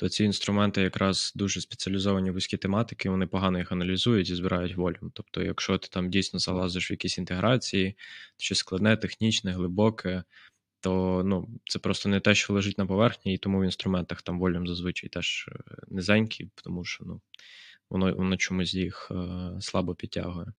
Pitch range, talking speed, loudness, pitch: 90-100 Hz, 165 wpm, -28 LUFS, 95 Hz